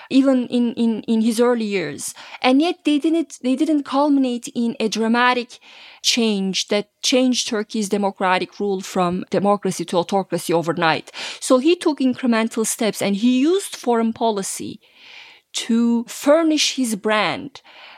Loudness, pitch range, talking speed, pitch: -19 LUFS, 205-265 Hz, 140 wpm, 235 Hz